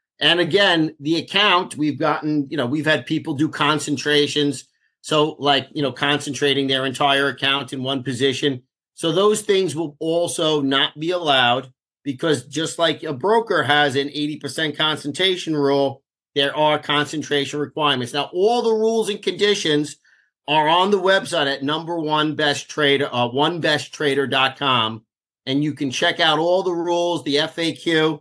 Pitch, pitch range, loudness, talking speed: 150 Hz, 140-160 Hz, -19 LUFS, 160 wpm